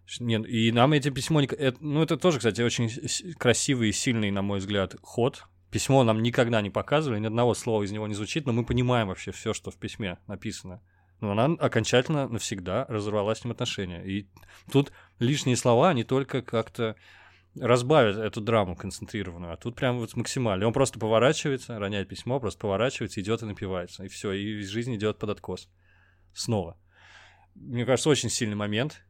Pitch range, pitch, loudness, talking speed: 100-125 Hz, 110 Hz, -27 LUFS, 175 wpm